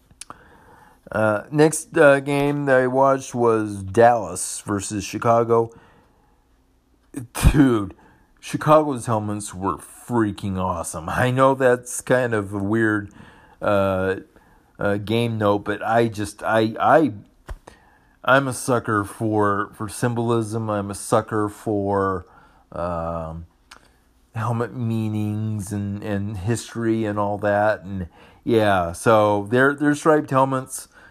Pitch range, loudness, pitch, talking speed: 100-120 Hz, -21 LUFS, 110 Hz, 115 wpm